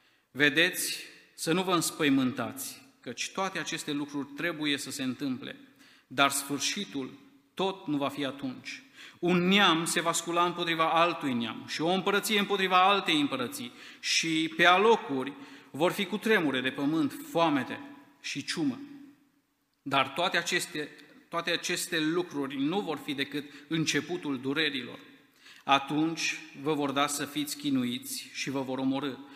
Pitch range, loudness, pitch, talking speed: 145-230 Hz, -29 LUFS, 170 Hz, 140 wpm